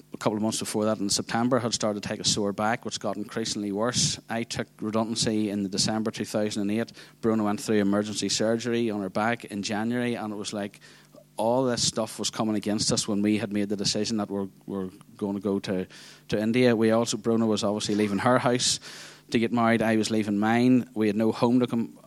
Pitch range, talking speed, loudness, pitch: 105-115 Hz, 235 wpm, -26 LUFS, 110 Hz